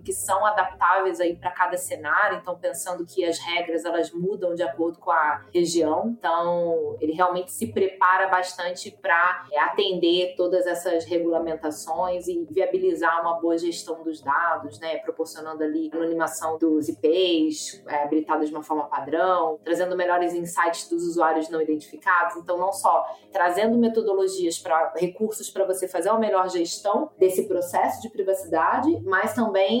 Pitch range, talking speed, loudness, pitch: 165-190 Hz, 155 wpm, -24 LUFS, 175 Hz